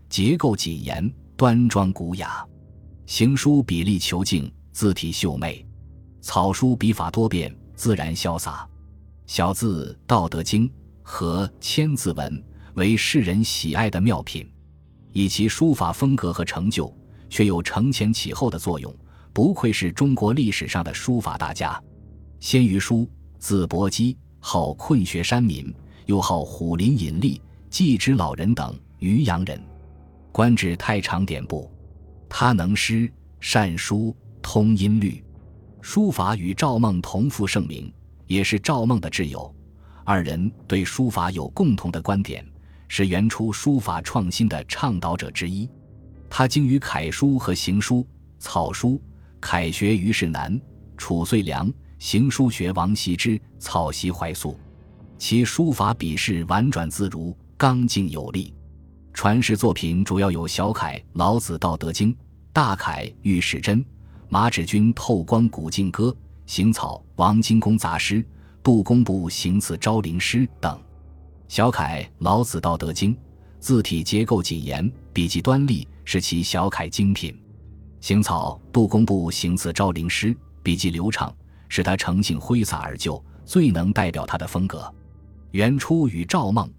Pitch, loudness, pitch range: 95 Hz, -22 LUFS, 80-110 Hz